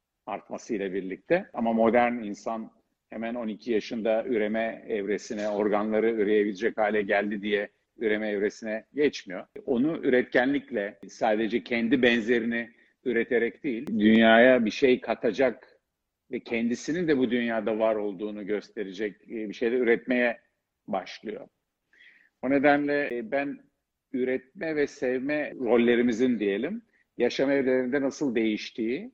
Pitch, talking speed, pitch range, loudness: 115 Hz, 110 wpm, 110-125 Hz, -26 LUFS